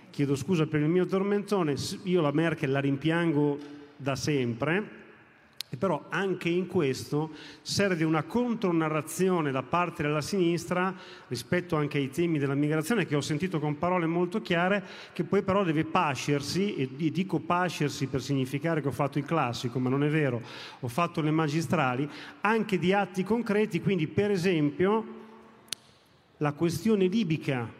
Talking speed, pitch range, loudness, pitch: 155 wpm, 145-185 Hz, -28 LUFS, 160 Hz